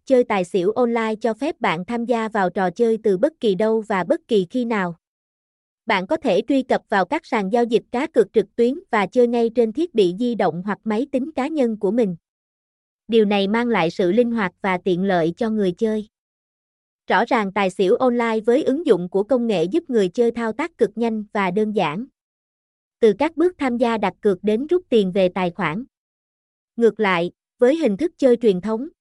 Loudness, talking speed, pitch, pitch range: -20 LUFS, 215 wpm, 225 Hz, 195-250 Hz